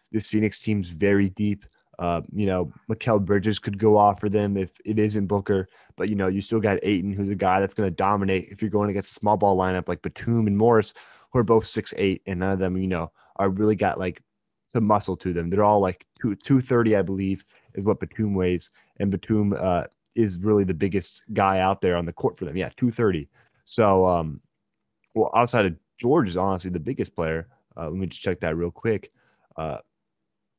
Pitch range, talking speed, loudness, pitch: 95-105 Hz, 225 wpm, -24 LUFS, 100 Hz